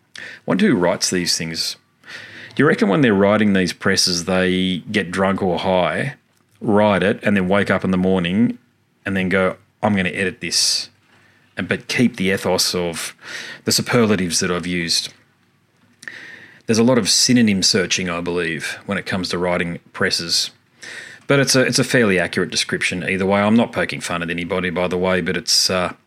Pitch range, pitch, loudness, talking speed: 90-105 Hz, 95 Hz, -18 LUFS, 190 wpm